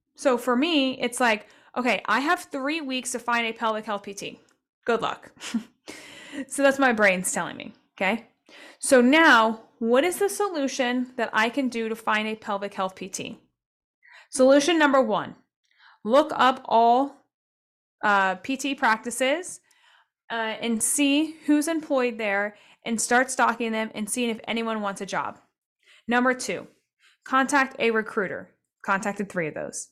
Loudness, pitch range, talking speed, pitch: -24 LUFS, 220-275 Hz, 150 wpm, 245 Hz